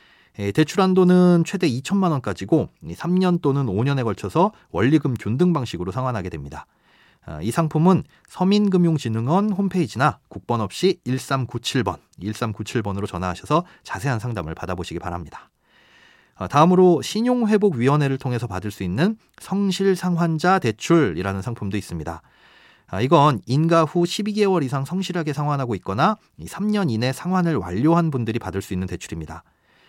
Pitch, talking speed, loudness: 135 Hz, 325 characters per minute, -21 LUFS